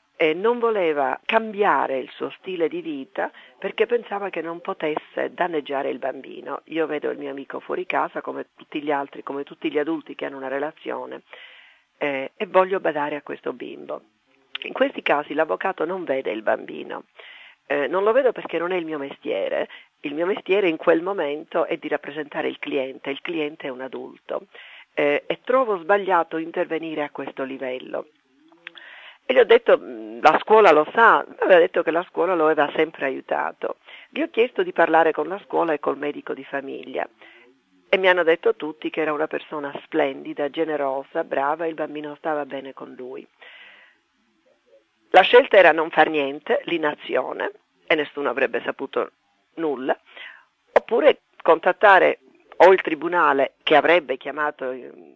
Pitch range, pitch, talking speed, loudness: 145-225 Hz, 160 Hz, 170 wpm, -22 LUFS